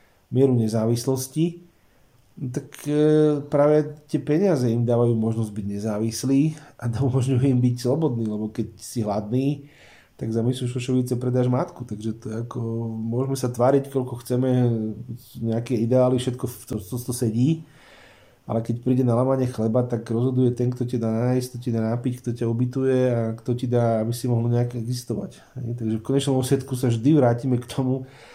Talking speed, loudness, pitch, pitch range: 175 wpm, -23 LUFS, 125 Hz, 115-130 Hz